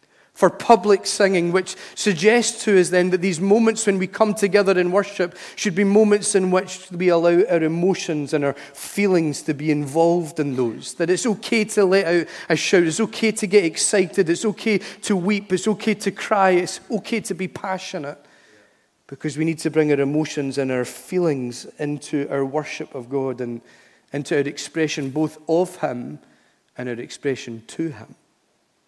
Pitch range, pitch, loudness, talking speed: 150-200 Hz, 180 Hz, -20 LUFS, 180 wpm